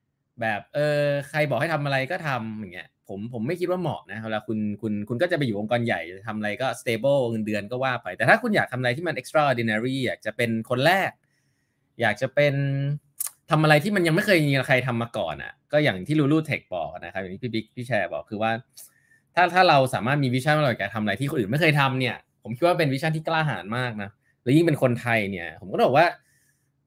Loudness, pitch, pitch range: -24 LUFS, 130 Hz, 115-150 Hz